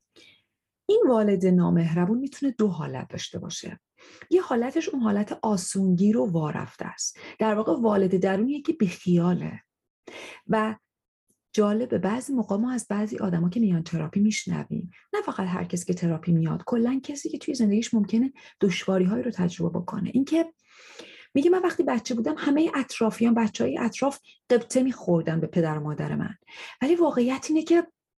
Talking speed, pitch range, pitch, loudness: 155 wpm, 185-270 Hz, 220 Hz, -25 LUFS